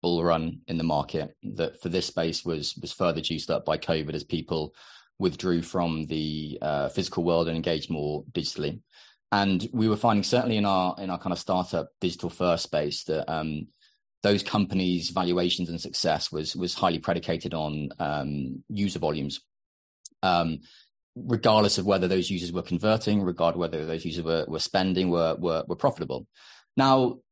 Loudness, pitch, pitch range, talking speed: -27 LUFS, 85 Hz, 80-95 Hz, 170 wpm